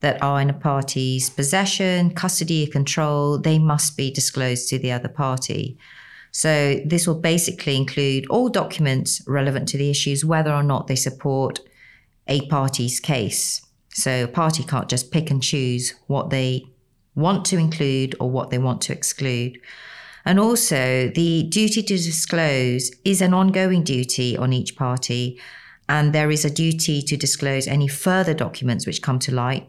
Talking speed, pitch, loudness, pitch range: 165 wpm, 140 Hz, -21 LUFS, 130-160 Hz